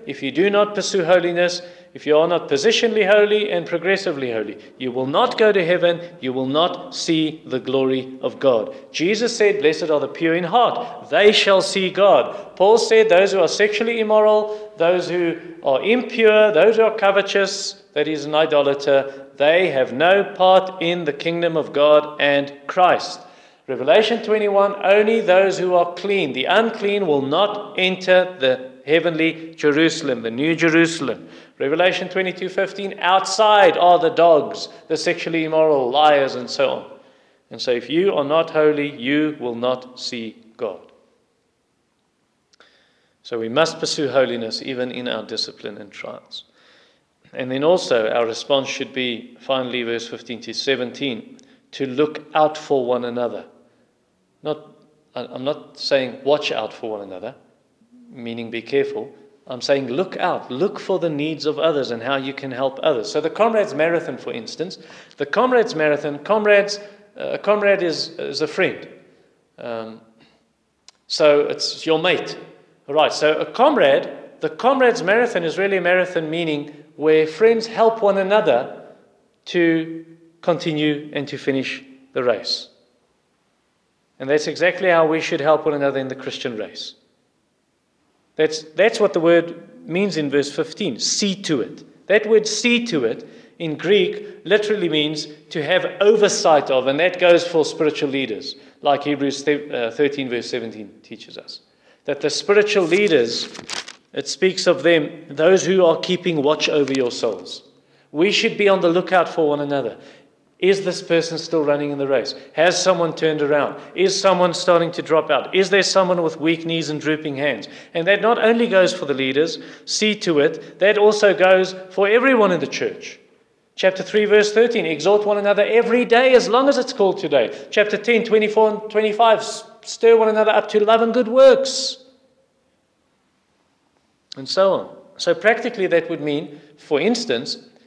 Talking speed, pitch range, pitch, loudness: 165 wpm, 150-210 Hz, 170 Hz, -18 LUFS